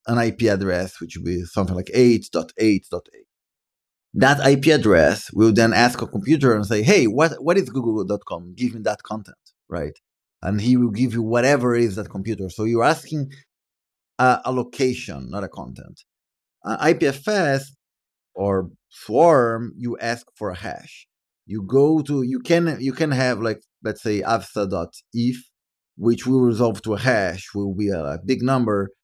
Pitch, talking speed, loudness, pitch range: 115 Hz, 165 wpm, -20 LUFS, 100-130 Hz